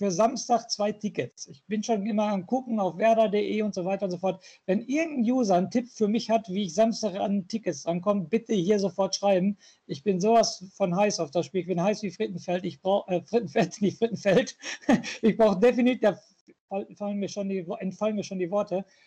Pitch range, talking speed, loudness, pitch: 190-220 Hz, 200 wpm, -27 LUFS, 205 Hz